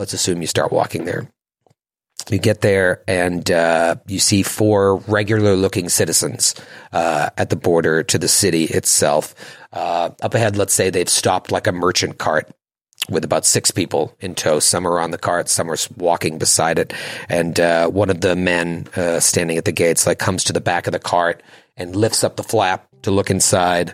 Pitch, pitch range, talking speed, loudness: 90 Hz, 85-100 Hz, 200 wpm, -17 LUFS